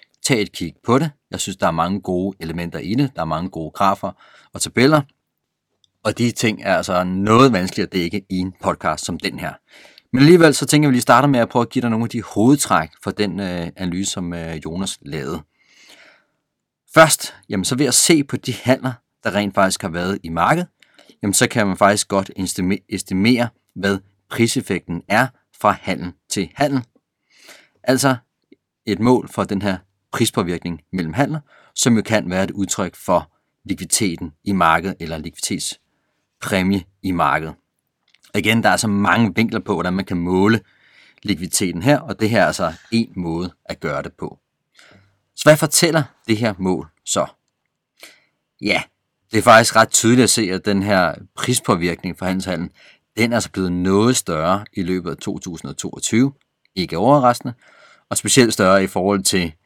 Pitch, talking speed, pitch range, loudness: 100 Hz, 180 wpm, 90-120 Hz, -18 LUFS